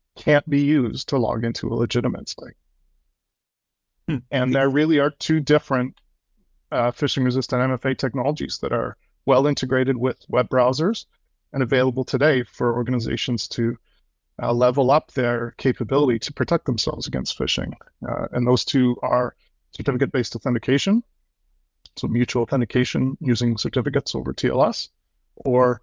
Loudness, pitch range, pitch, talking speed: -22 LUFS, 120-140 Hz, 125 Hz, 135 wpm